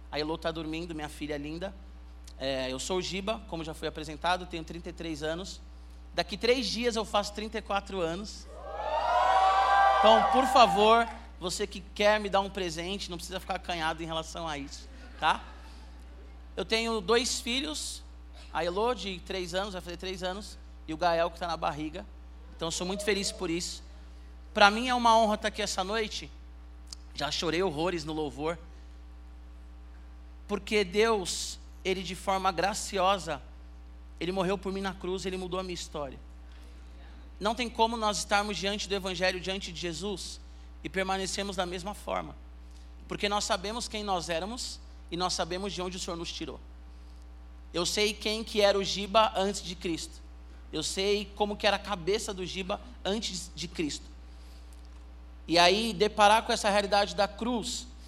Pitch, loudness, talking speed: 180 Hz, -30 LUFS, 170 wpm